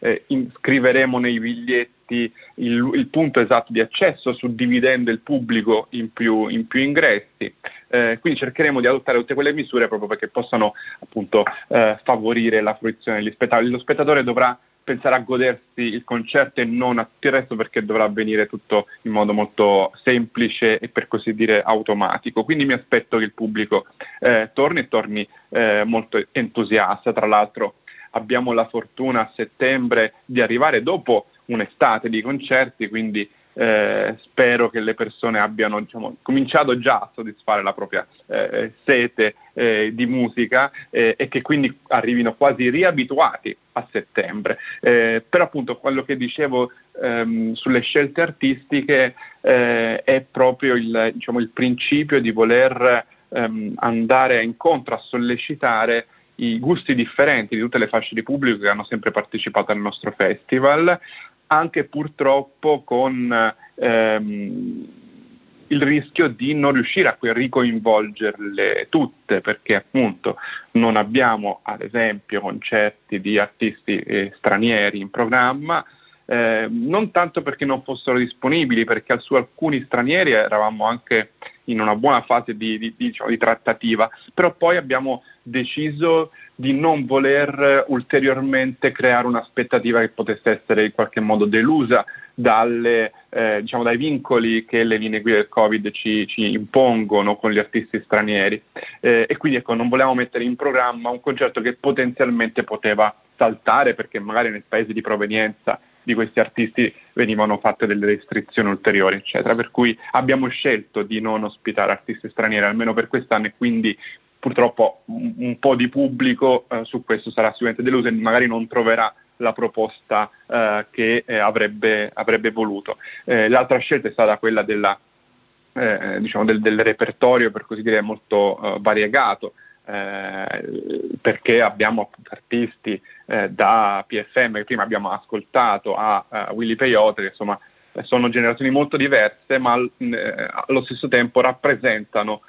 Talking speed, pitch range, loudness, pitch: 150 wpm, 110-135 Hz, -19 LUFS, 120 Hz